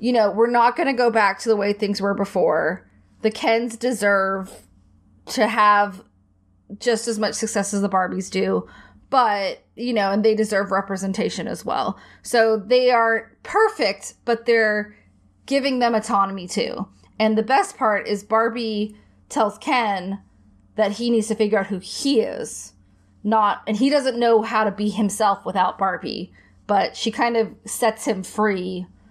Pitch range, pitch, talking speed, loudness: 195-230 Hz, 215 Hz, 165 wpm, -21 LUFS